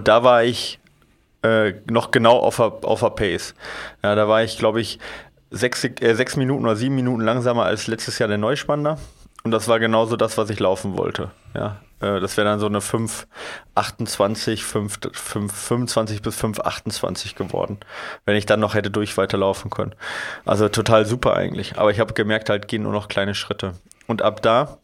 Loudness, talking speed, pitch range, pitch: -21 LUFS, 180 wpm, 105-115 Hz, 110 Hz